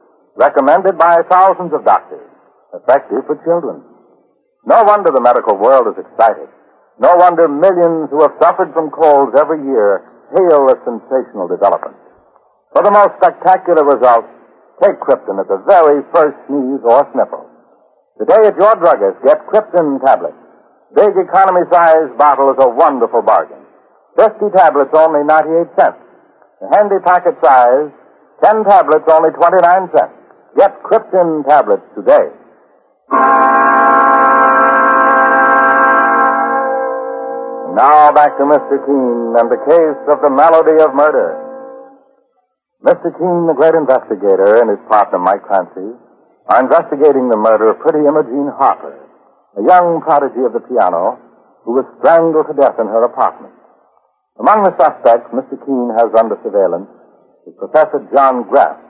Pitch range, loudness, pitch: 140-190 Hz, -11 LUFS, 160 Hz